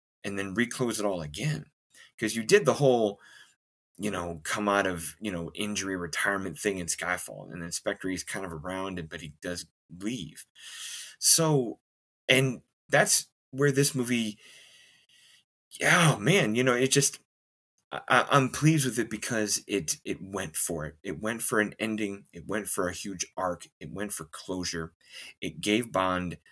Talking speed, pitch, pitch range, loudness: 175 wpm, 105 Hz, 85-120 Hz, -27 LUFS